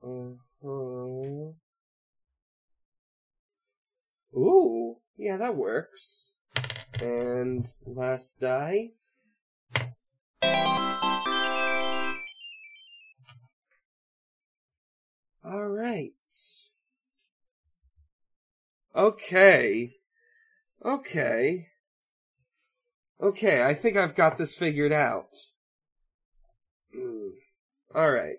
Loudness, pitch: -26 LUFS, 165 Hz